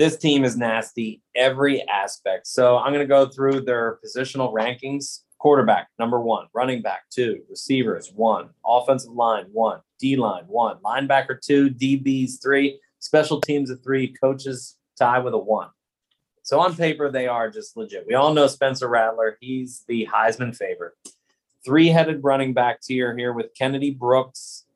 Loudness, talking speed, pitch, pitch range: -21 LUFS, 160 wpm, 135 Hz, 125-140 Hz